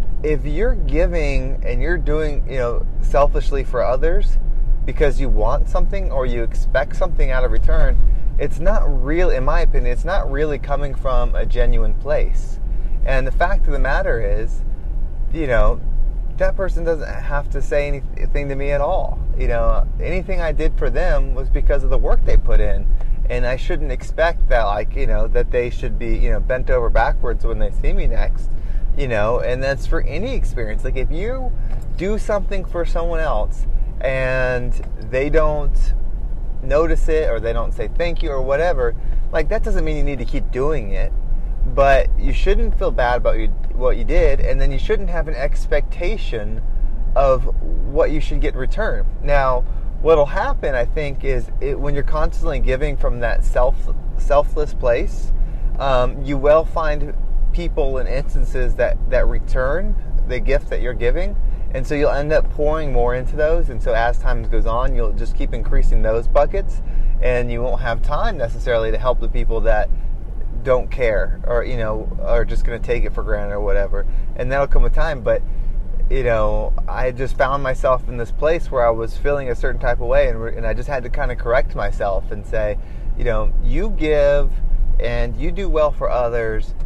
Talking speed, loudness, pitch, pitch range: 195 wpm, -21 LUFS, 130 Hz, 115-145 Hz